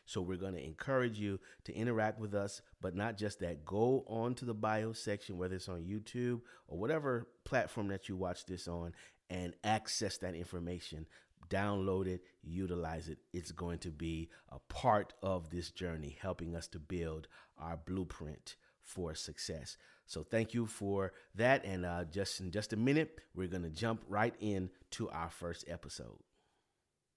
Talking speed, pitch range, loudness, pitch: 170 wpm, 85-105 Hz, -40 LUFS, 95 Hz